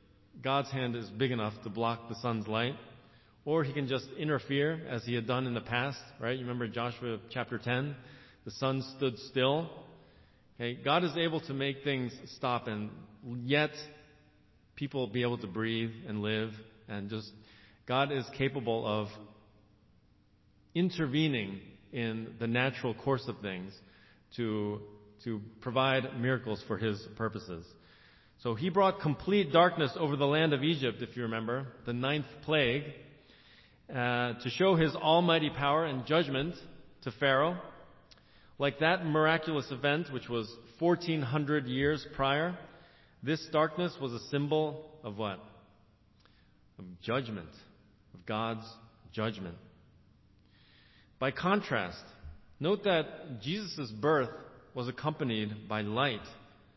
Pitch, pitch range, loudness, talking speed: 120 Hz, 110-145 Hz, -33 LUFS, 135 wpm